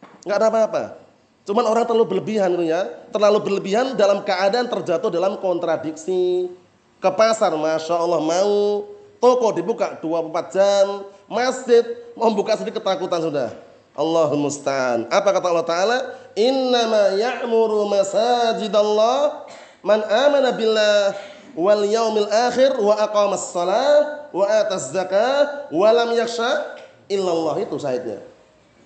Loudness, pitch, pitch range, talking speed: -19 LUFS, 210 Hz, 185-235 Hz, 120 wpm